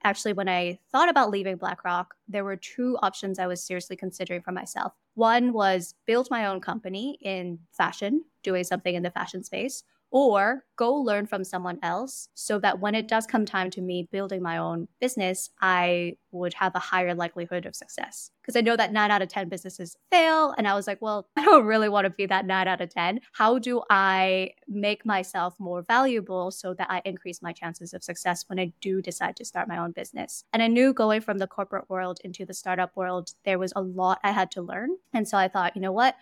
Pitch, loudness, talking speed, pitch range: 190 Hz, -26 LUFS, 225 wpm, 180-215 Hz